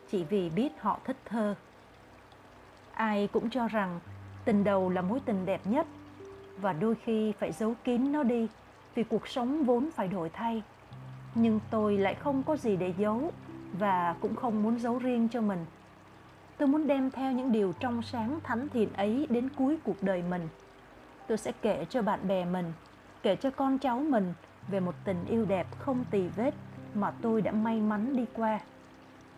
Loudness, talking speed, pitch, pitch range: -31 LUFS, 185 wpm, 215 Hz, 190-245 Hz